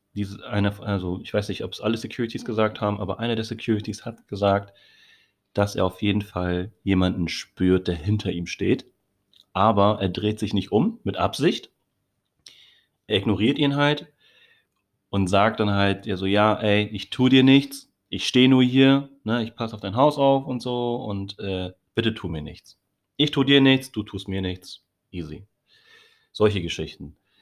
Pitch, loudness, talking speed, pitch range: 105 Hz, -23 LUFS, 175 wpm, 95-120 Hz